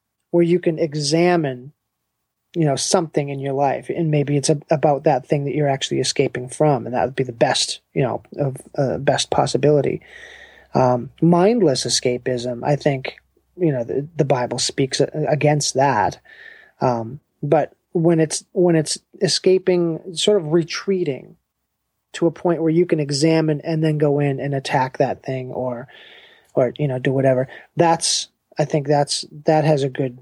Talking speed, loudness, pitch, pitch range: 170 wpm, -19 LUFS, 150 Hz, 135-165 Hz